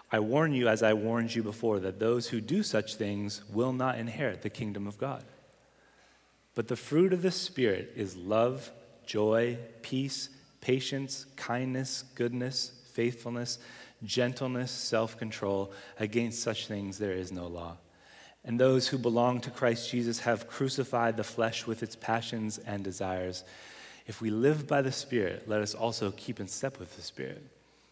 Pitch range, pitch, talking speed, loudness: 105-130 Hz, 115 Hz, 165 wpm, -32 LUFS